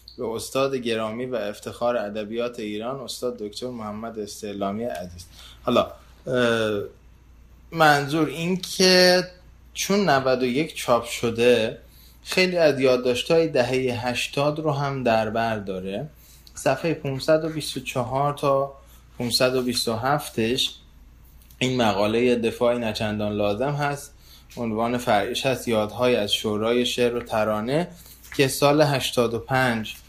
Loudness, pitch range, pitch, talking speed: -23 LUFS, 105-135 Hz, 120 Hz, 105 wpm